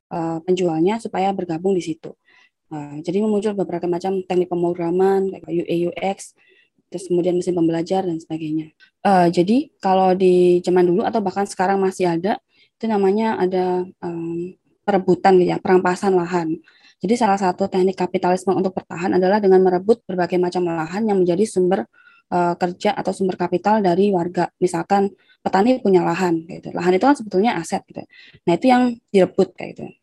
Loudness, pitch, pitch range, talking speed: -19 LUFS, 185 Hz, 175-195 Hz, 150 wpm